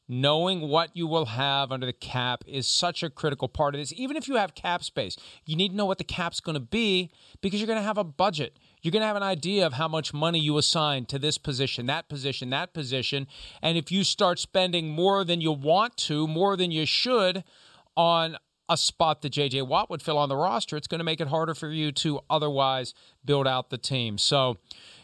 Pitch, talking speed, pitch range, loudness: 155 Hz, 235 wpm, 140-175 Hz, -26 LUFS